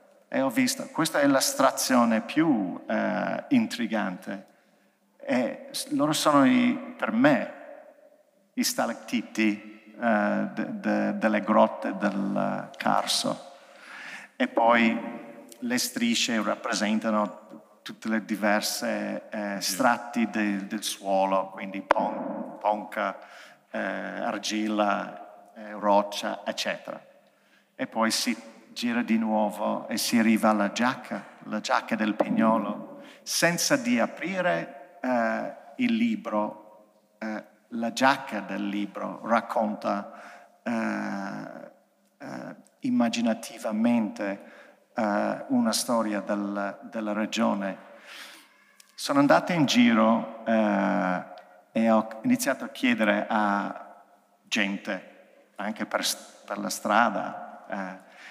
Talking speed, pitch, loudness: 100 wpm, 115 Hz, -26 LUFS